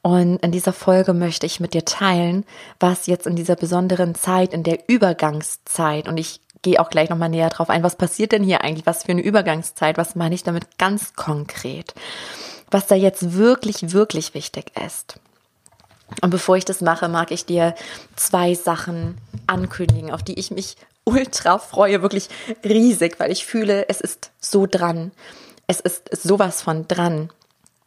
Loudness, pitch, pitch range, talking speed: -19 LUFS, 180 Hz, 165-195 Hz, 170 wpm